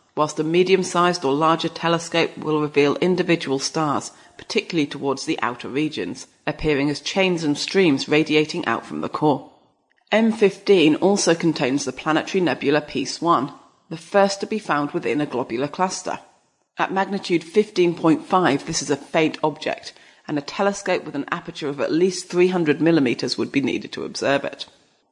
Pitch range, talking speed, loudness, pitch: 150-185 Hz, 165 wpm, -21 LUFS, 165 Hz